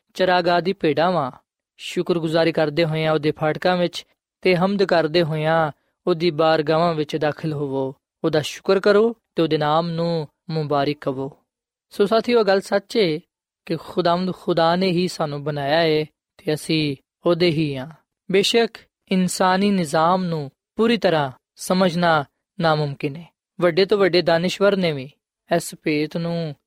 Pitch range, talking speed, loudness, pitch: 155-185 Hz, 140 wpm, -20 LUFS, 170 Hz